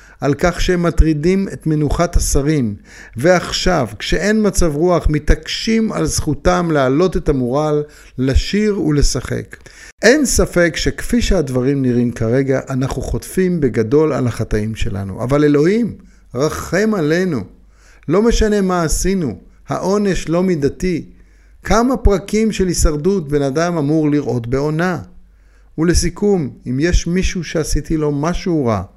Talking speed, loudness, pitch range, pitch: 120 wpm, -16 LUFS, 135-185 Hz, 155 Hz